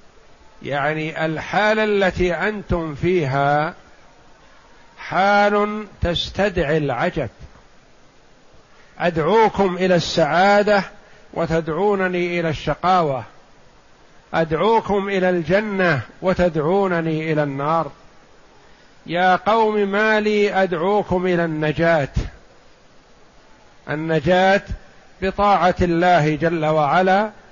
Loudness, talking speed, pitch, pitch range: -19 LUFS, 70 wpm, 180 Hz, 160-200 Hz